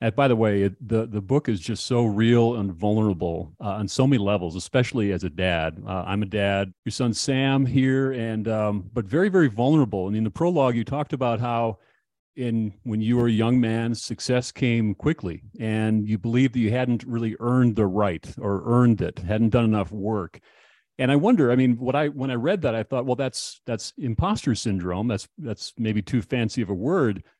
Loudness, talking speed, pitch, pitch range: -24 LUFS, 215 wpm, 115 Hz, 105-125 Hz